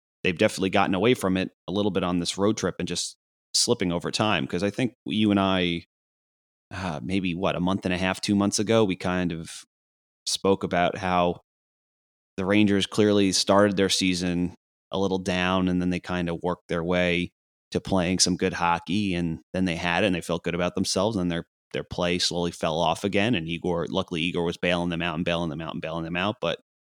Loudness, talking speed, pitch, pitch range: -25 LUFS, 220 wpm, 90 Hz, 85-95 Hz